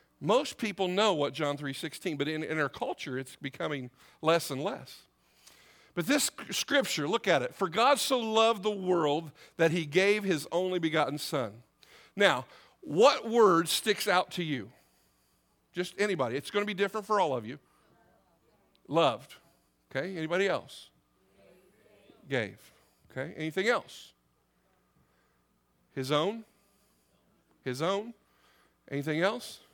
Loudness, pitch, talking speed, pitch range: -30 LUFS, 155 Hz, 135 wpm, 130-195 Hz